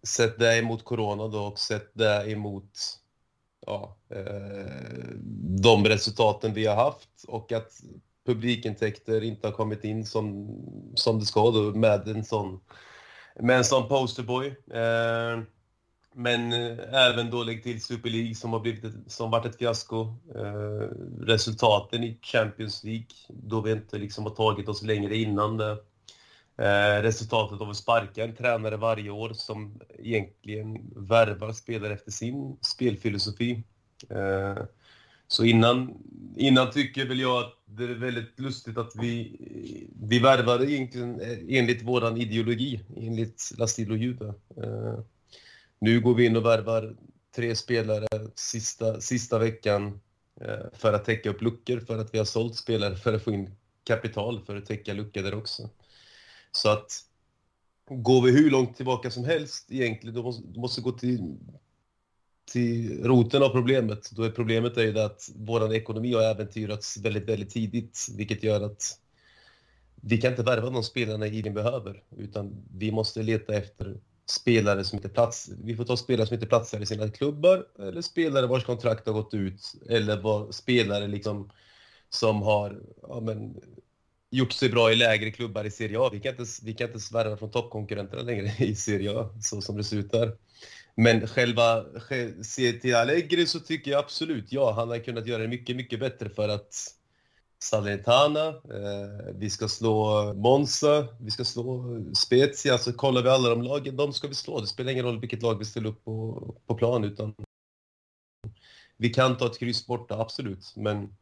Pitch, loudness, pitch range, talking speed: 115 Hz, -27 LUFS, 105-120 Hz, 165 wpm